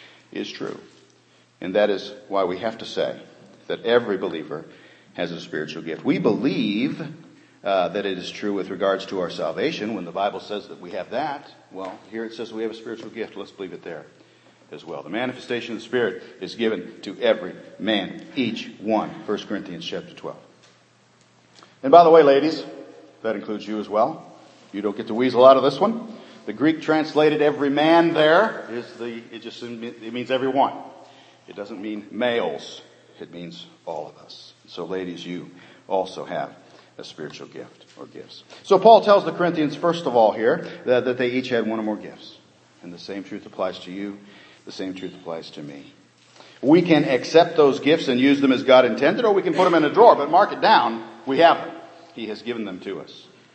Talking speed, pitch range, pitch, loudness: 205 wpm, 100-145 Hz, 115 Hz, -21 LUFS